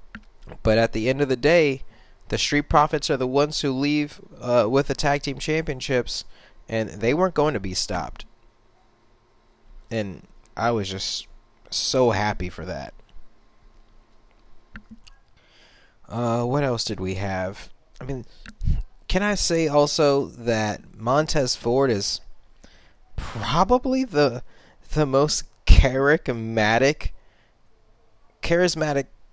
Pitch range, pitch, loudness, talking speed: 110-145 Hz, 125 Hz, -23 LUFS, 120 wpm